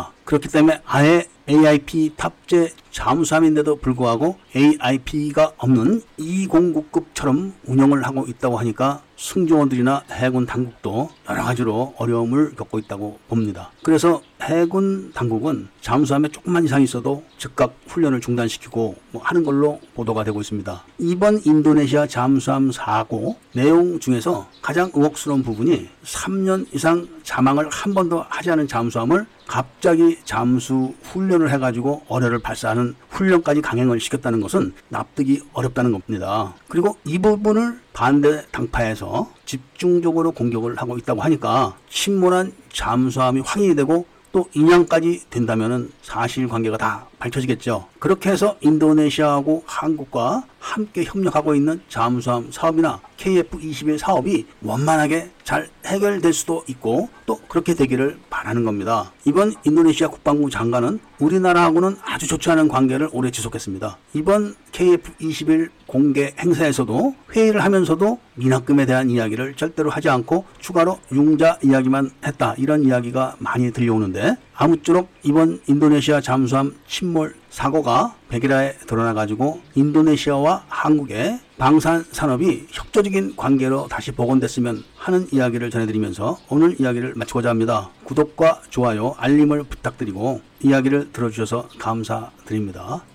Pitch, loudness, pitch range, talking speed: 145 Hz, -19 LUFS, 125-165 Hz, 340 characters per minute